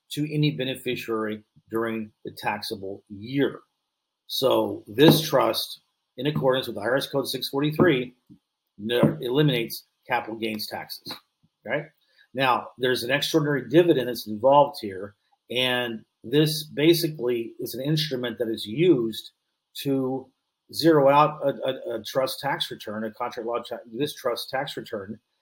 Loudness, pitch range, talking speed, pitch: -25 LUFS, 115-145 Hz, 135 wpm, 130 Hz